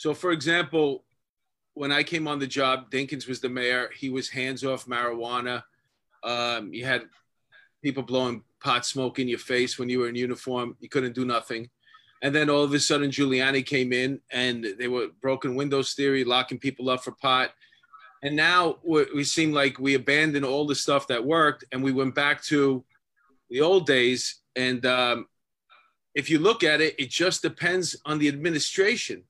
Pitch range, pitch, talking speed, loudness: 125-150 Hz, 135 Hz, 185 wpm, -25 LUFS